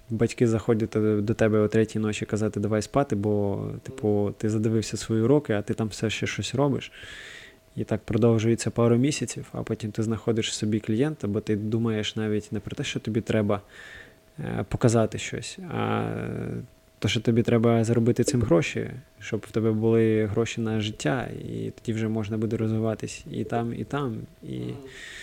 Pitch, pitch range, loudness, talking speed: 110 Hz, 110-115 Hz, -26 LUFS, 175 wpm